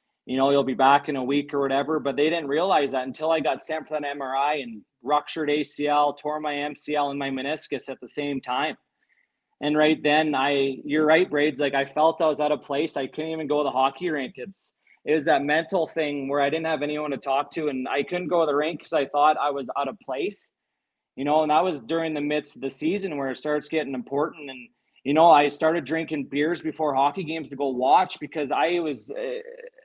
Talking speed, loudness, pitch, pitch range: 240 wpm, -24 LUFS, 150 Hz, 140-155 Hz